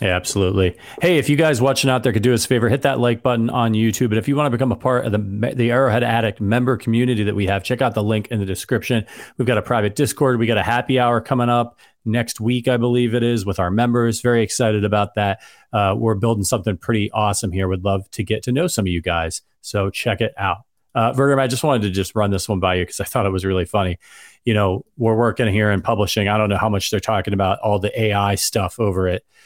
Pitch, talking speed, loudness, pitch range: 110 Hz, 265 wpm, -19 LUFS, 100-120 Hz